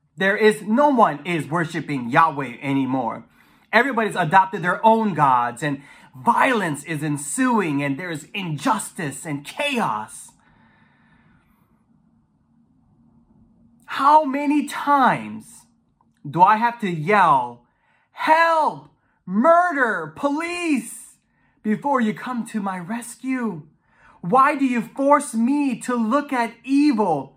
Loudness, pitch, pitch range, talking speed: -20 LUFS, 215 Hz, 160-265 Hz, 105 wpm